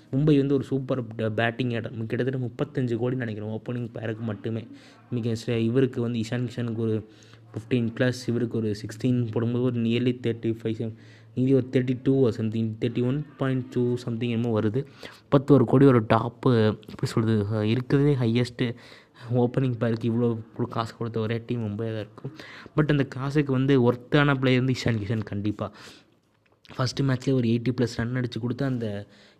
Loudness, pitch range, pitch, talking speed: -26 LUFS, 115-130 Hz, 120 Hz, 160 wpm